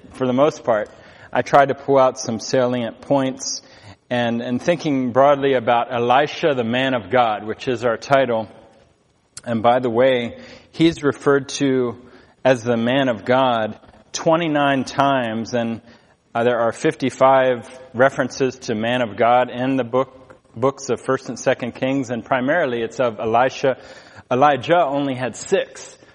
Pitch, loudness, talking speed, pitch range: 130 Hz, -19 LUFS, 155 wpm, 120-135 Hz